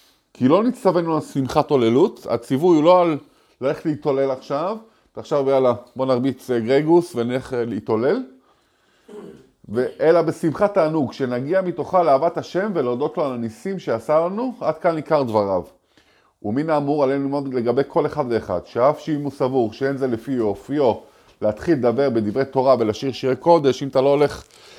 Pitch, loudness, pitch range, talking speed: 140 Hz, -20 LUFS, 130-165 Hz, 155 wpm